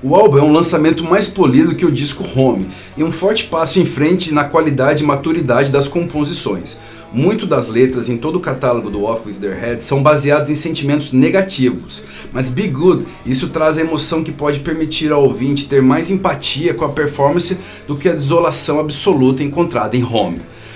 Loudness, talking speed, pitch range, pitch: -14 LUFS, 190 wpm, 130-165 Hz, 150 Hz